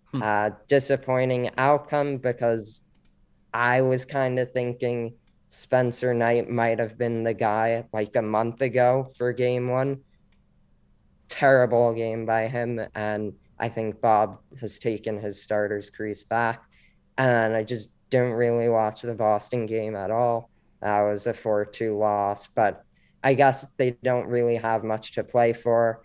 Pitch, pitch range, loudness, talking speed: 115 Hz, 110-125 Hz, -25 LUFS, 150 wpm